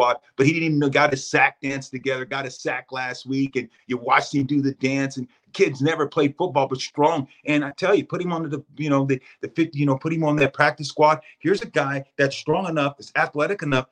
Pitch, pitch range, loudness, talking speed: 140 Hz, 135-150 Hz, -22 LUFS, 255 wpm